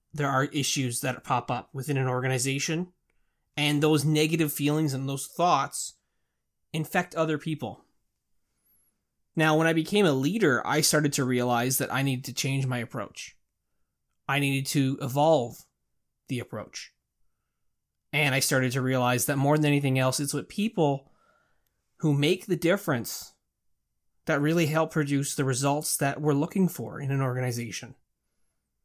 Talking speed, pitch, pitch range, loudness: 150 wpm, 140 Hz, 130-155 Hz, -26 LUFS